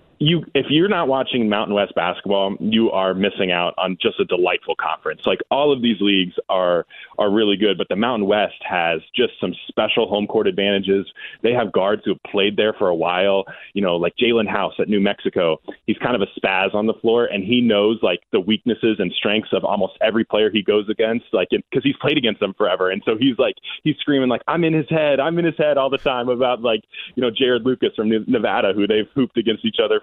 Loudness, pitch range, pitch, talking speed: -19 LUFS, 100-140 Hz, 115 Hz, 235 wpm